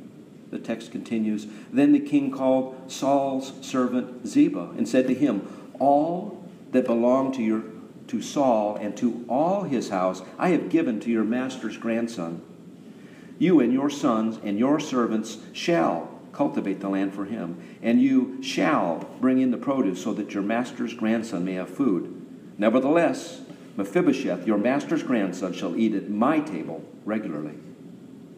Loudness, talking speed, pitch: -25 LUFS, 150 wpm, 125 Hz